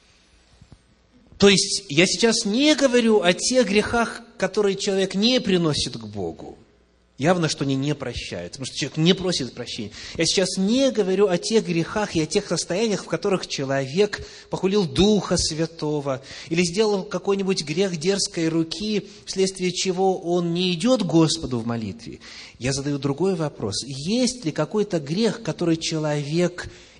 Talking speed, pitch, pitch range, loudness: 150 wpm, 180 Hz, 150-200 Hz, -22 LUFS